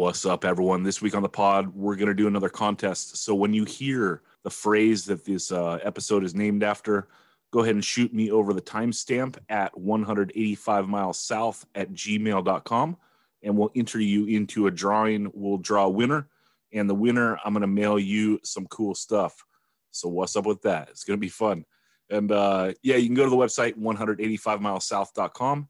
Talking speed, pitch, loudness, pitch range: 190 wpm, 105 Hz, -25 LUFS, 100-110 Hz